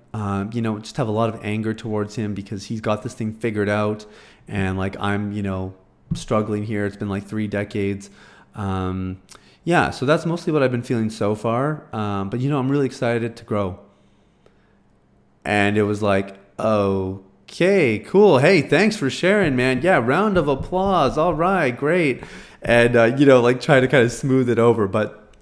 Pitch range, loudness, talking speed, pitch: 100-130 Hz, -20 LUFS, 190 wpm, 110 Hz